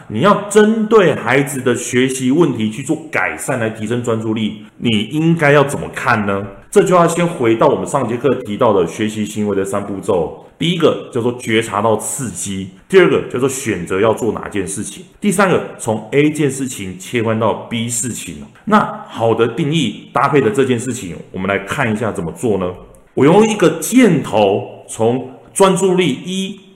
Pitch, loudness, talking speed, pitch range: 120 Hz, -15 LUFS, 270 characters per minute, 105-160 Hz